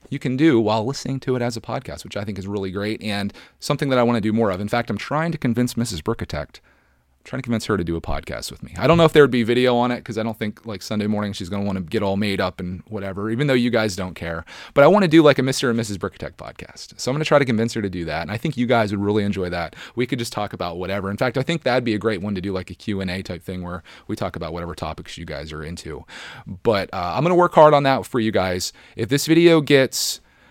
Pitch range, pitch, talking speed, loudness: 95-125 Hz, 110 Hz, 310 wpm, -21 LUFS